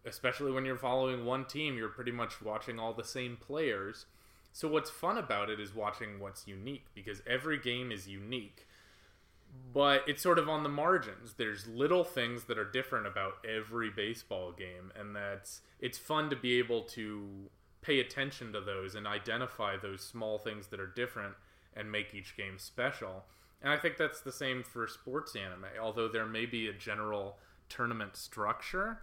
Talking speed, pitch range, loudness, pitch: 180 wpm, 100-125 Hz, -36 LUFS, 110 Hz